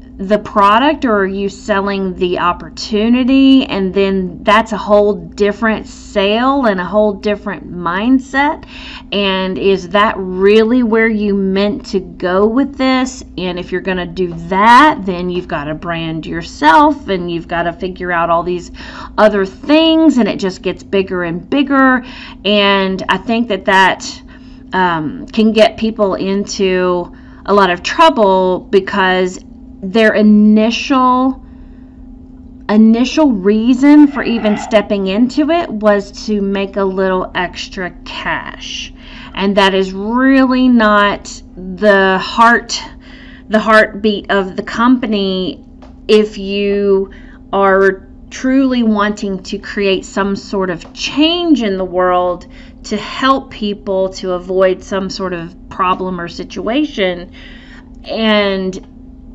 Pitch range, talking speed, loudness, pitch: 190-250 Hz, 130 wpm, -13 LUFS, 205 Hz